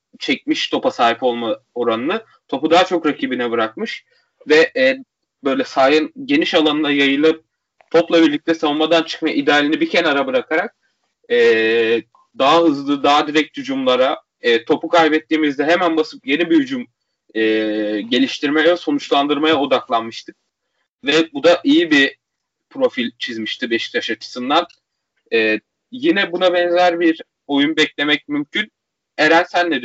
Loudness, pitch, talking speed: -17 LUFS, 165 Hz, 125 wpm